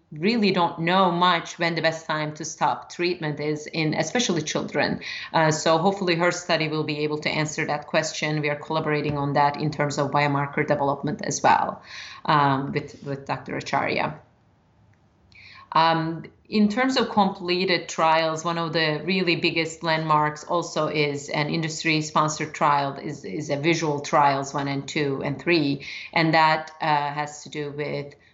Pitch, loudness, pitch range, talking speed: 155 Hz, -23 LUFS, 145-170 Hz, 165 wpm